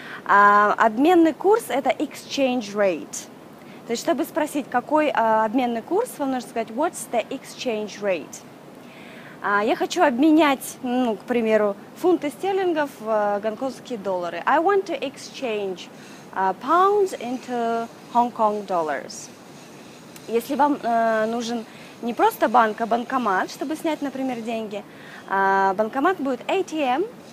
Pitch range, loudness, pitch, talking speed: 220-310 Hz, -22 LUFS, 245 Hz, 120 wpm